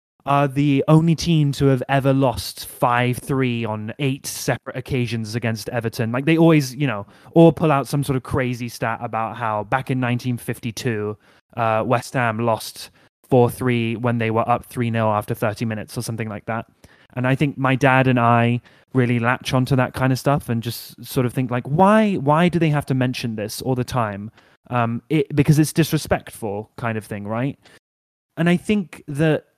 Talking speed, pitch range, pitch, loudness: 200 wpm, 115-140 Hz, 125 Hz, -20 LUFS